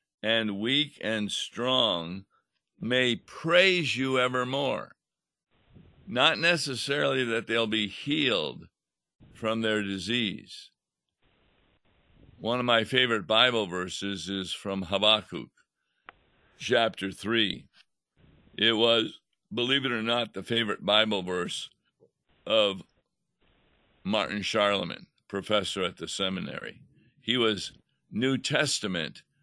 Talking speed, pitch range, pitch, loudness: 100 wpm, 100-125 Hz, 115 Hz, -27 LUFS